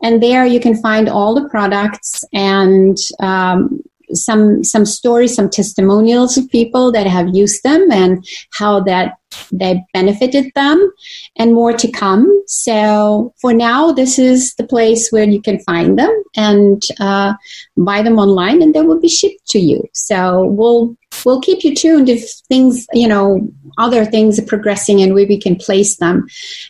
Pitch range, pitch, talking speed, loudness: 200-255 Hz, 220 Hz, 170 wpm, -11 LUFS